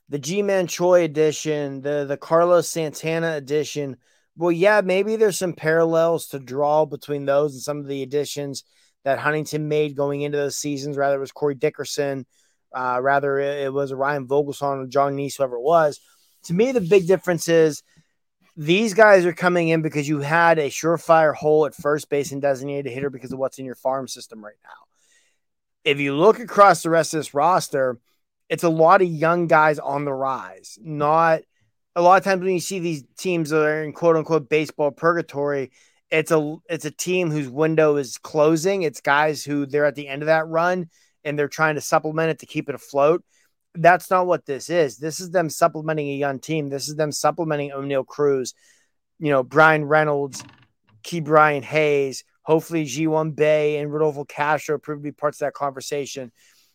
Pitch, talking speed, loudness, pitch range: 150 Hz, 195 wpm, -21 LUFS, 140-165 Hz